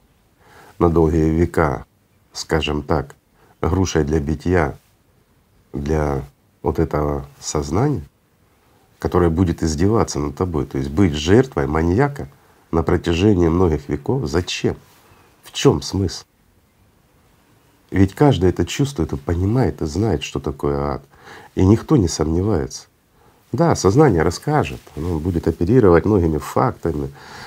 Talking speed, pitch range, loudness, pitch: 115 wpm, 75-95 Hz, -19 LUFS, 85 Hz